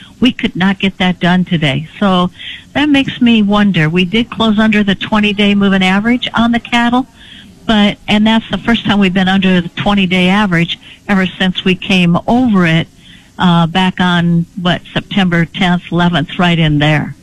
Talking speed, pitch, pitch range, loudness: 185 wpm, 190 Hz, 175-210 Hz, -12 LUFS